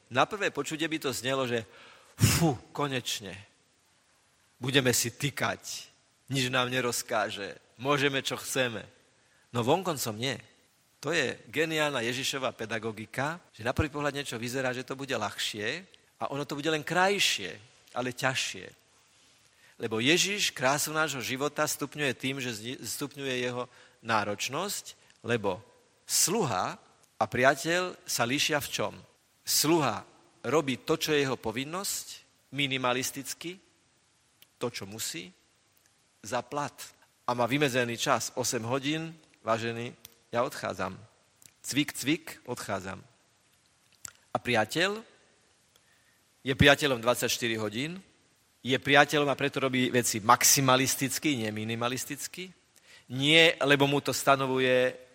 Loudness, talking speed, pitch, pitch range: -29 LUFS, 120 wpm, 130 Hz, 120-145 Hz